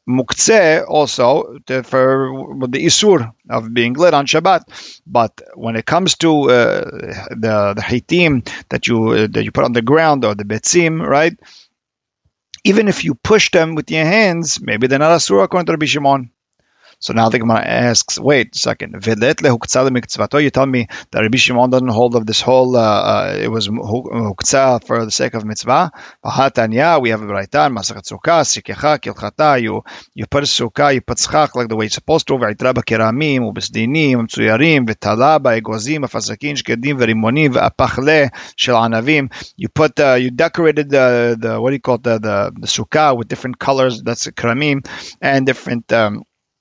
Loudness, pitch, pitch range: -14 LUFS, 125 Hz, 115-145 Hz